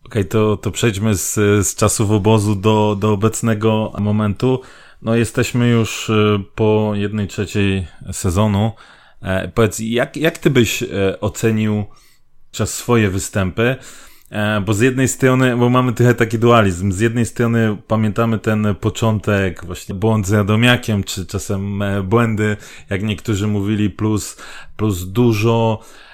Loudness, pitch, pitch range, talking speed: -17 LUFS, 110 Hz, 105-115 Hz, 130 wpm